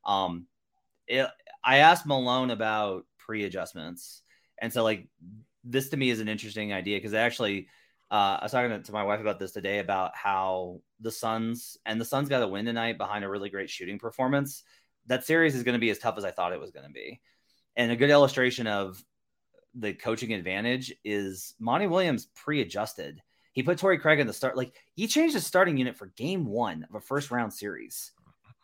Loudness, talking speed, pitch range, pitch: -28 LUFS, 200 wpm, 100-130 Hz, 115 Hz